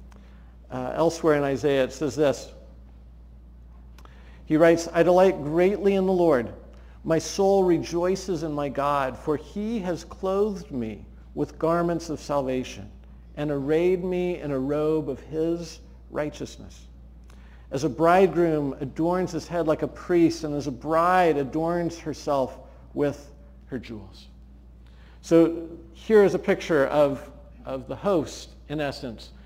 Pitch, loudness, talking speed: 145 Hz, -24 LUFS, 140 wpm